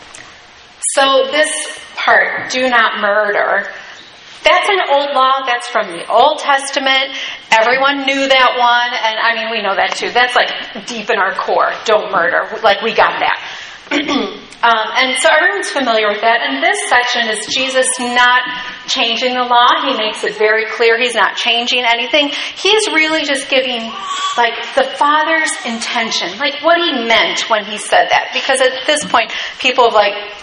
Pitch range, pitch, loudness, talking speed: 230-280 Hz, 250 Hz, -13 LUFS, 170 wpm